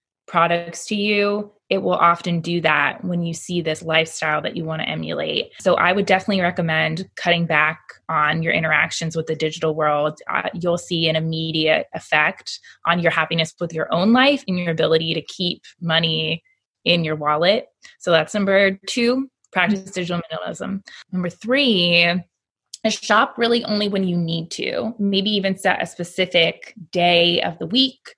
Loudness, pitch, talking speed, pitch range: -20 LUFS, 175 Hz, 170 wpm, 160-195 Hz